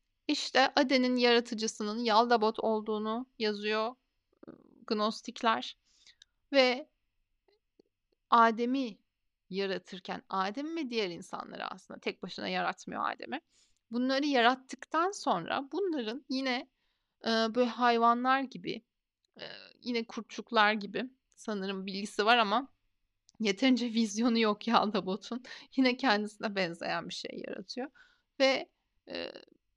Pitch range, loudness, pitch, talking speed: 215-265 Hz, -31 LUFS, 235 Hz, 95 wpm